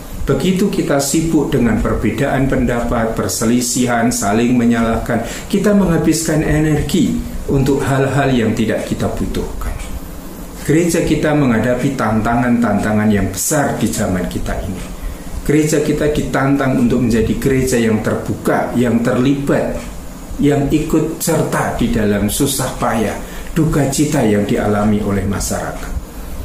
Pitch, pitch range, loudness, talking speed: 120 Hz, 110-145 Hz, -15 LUFS, 115 wpm